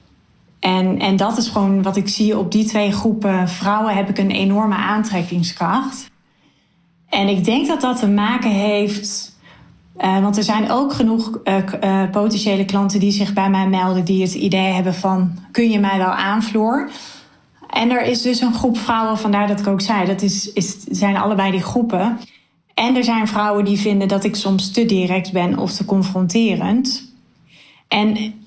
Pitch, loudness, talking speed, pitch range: 205 Hz, -17 LUFS, 180 wpm, 195-220 Hz